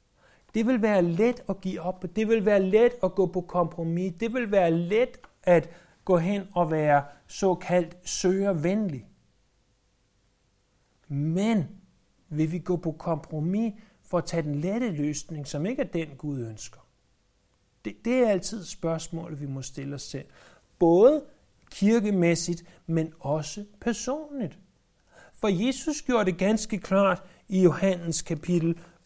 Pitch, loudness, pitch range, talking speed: 175 Hz, -26 LUFS, 155-205 Hz, 140 wpm